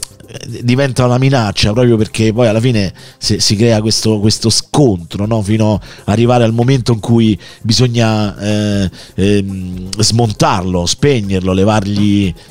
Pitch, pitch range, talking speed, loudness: 110 Hz, 100-120 Hz, 130 wpm, -13 LUFS